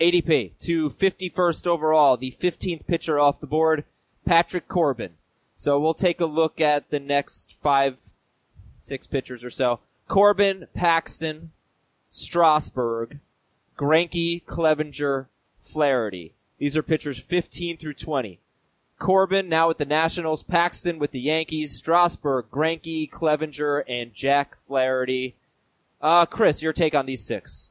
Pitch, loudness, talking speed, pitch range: 155 Hz, -23 LUFS, 130 wpm, 140-170 Hz